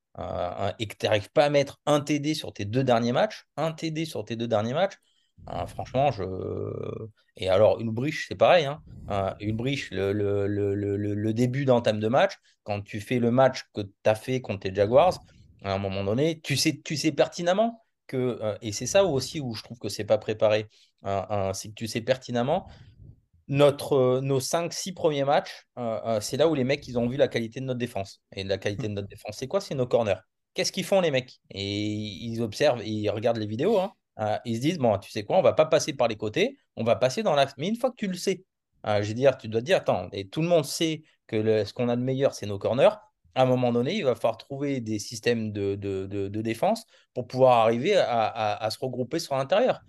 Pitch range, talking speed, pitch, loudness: 105-145 Hz, 250 wpm, 120 Hz, -26 LUFS